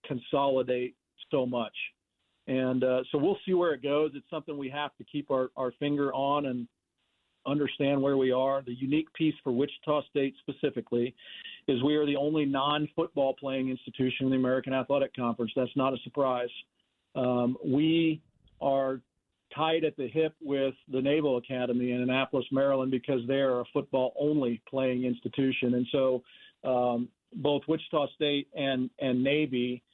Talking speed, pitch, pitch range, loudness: 160 wpm, 135 Hz, 125-145 Hz, -30 LUFS